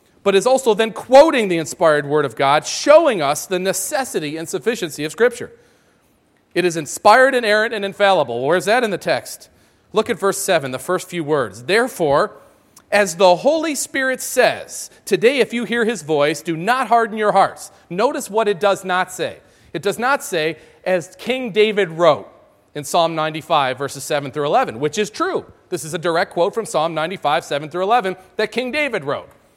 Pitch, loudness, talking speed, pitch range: 195 Hz, -18 LUFS, 195 wpm, 165-235 Hz